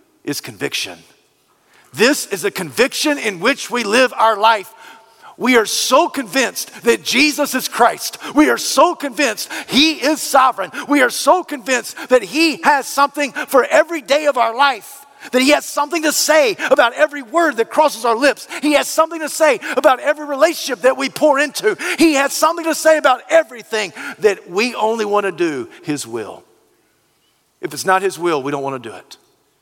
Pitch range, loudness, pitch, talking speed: 235-305 Hz, -15 LUFS, 280 Hz, 185 wpm